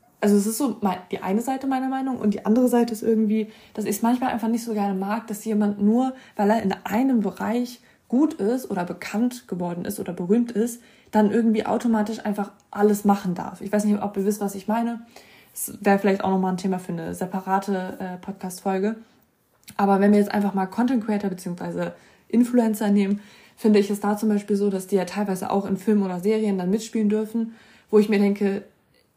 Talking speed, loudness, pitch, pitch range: 210 wpm, -23 LUFS, 210 Hz, 195-225 Hz